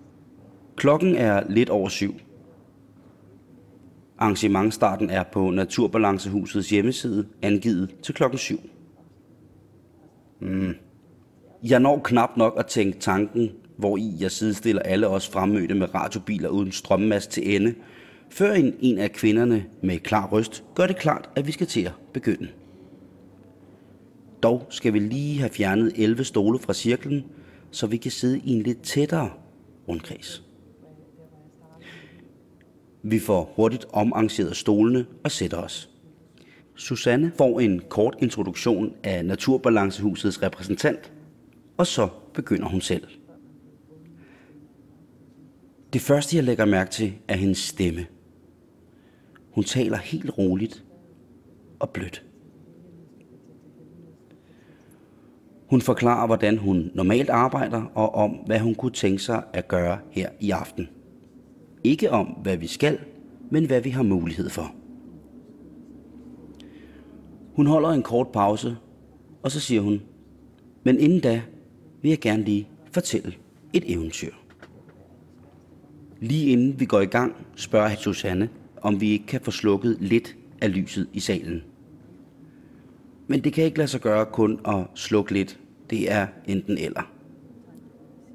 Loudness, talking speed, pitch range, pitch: -24 LUFS, 130 wpm, 95-125 Hz, 110 Hz